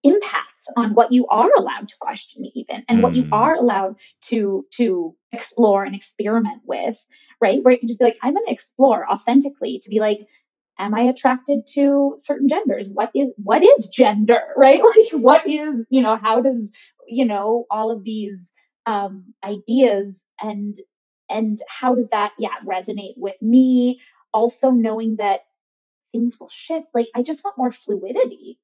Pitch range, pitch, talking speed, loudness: 210-270 Hz, 235 Hz, 170 wpm, -18 LUFS